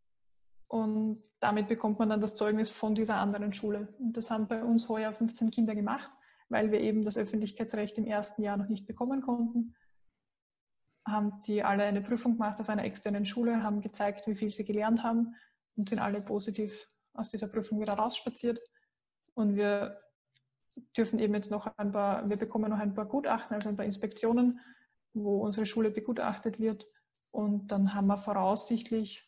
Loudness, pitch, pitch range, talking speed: -33 LUFS, 215 Hz, 205-225 Hz, 175 wpm